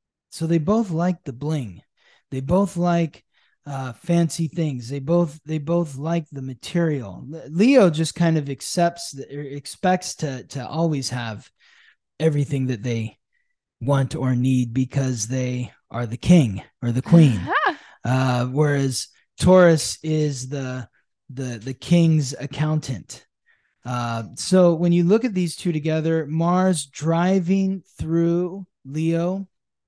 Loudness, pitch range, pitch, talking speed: -22 LUFS, 130-170 Hz, 155 Hz, 135 wpm